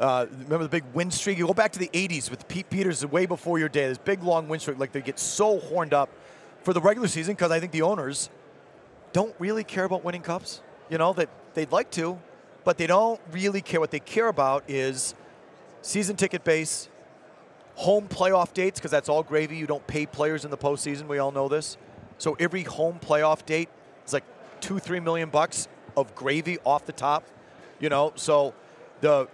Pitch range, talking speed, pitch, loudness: 145-185 Hz, 210 wpm, 165 Hz, -26 LUFS